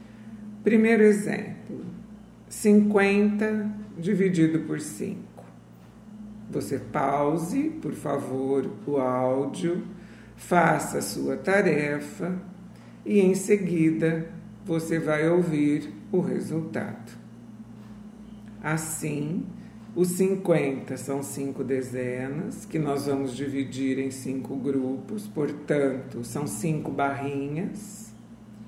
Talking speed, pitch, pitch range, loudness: 85 wpm, 155 Hz, 135-200 Hz, -26 LUFS